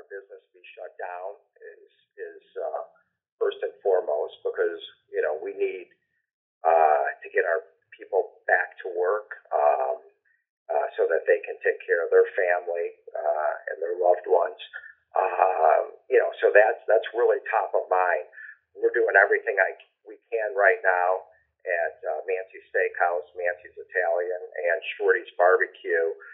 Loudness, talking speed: -25 LUFS, 150 wpm